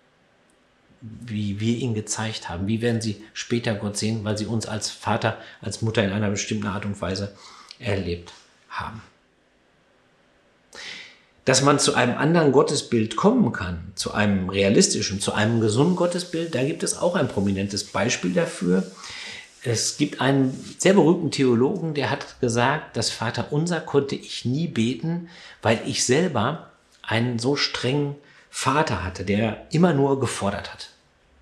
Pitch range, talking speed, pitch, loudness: 100-135 Hz, 150 wpm, 110 Hz, -23 LUFS